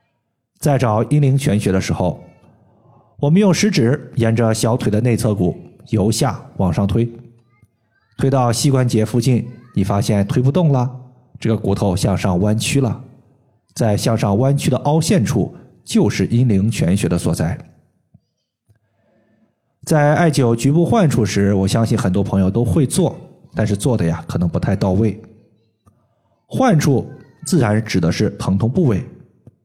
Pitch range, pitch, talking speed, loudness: 105-130 Hz, 115 Hz, 220 characters per minute, -17 LUFS